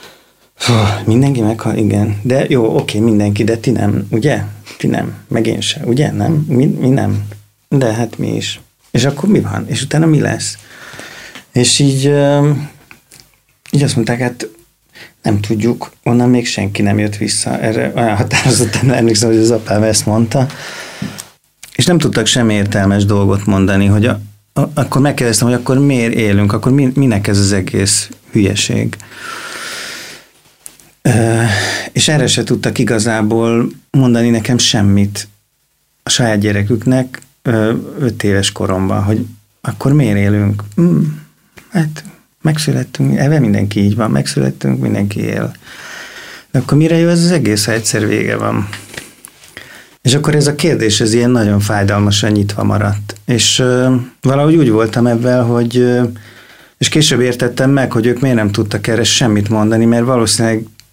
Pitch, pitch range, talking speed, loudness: 115 Hz, 105-130 Hz, 150 wpm, -13 LUFS